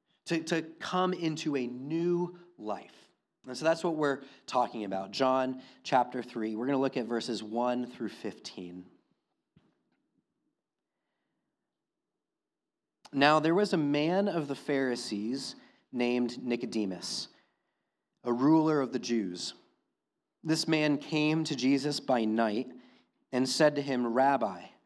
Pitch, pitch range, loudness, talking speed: 135 Hz, 120-160 Hz, -31 LUFS, 130 wpm